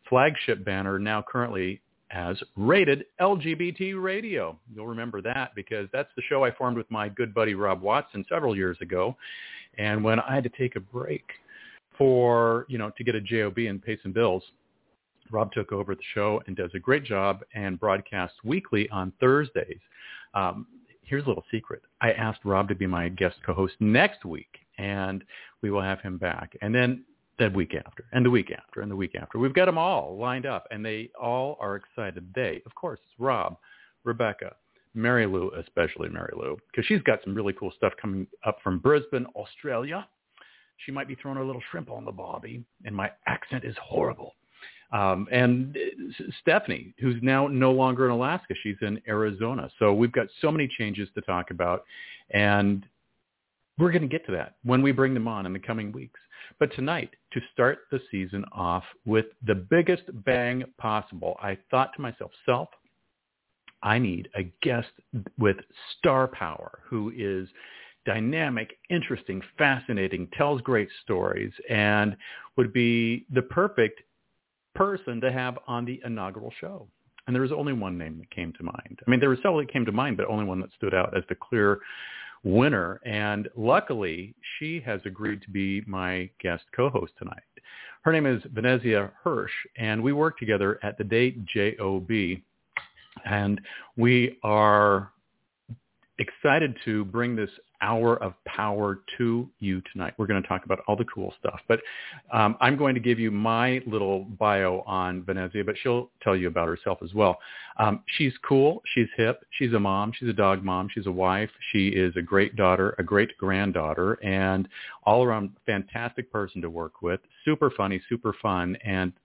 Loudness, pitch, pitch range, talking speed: -27 LUFS, 110 Hz, 95-125 Hz, 180 wpm